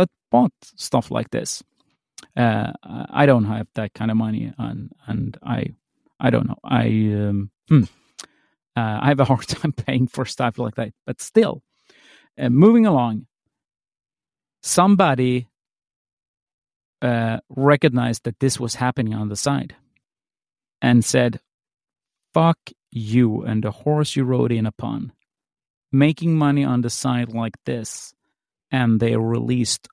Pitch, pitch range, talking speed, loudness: 125 Hz, 115-140 Hz, 135 wpm, -20 LUFS